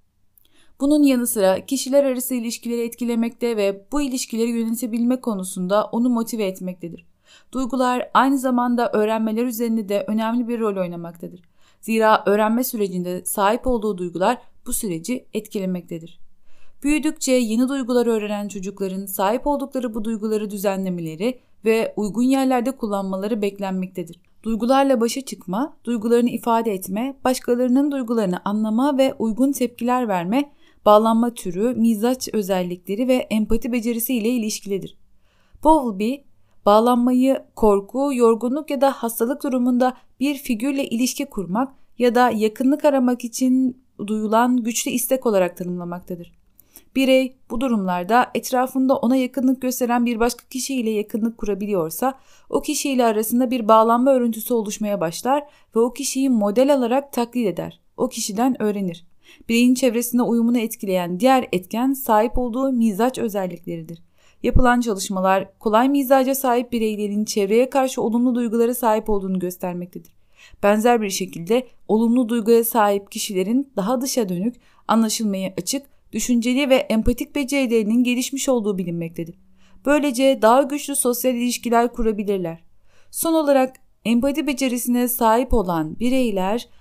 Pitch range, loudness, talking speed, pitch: 210-255 Hz, -20 LUFS, 125 wpm, 235 Hz